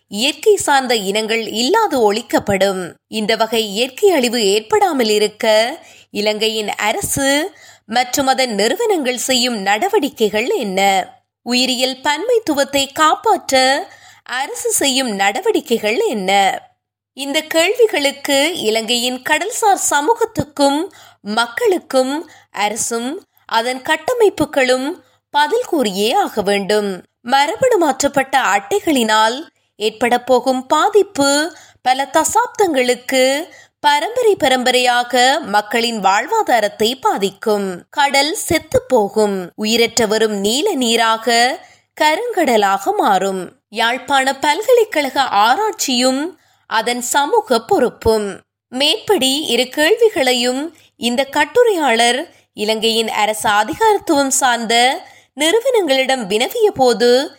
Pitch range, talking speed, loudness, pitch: 225-335 Hz, 80 wpm, -15 LUFS, 265 Hz